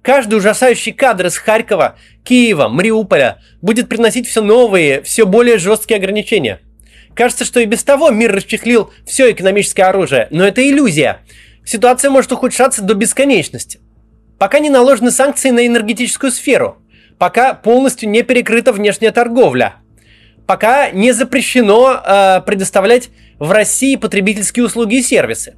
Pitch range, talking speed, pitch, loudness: 200-250 Hz, 135 wpm, 230 Hz, -11 LUFS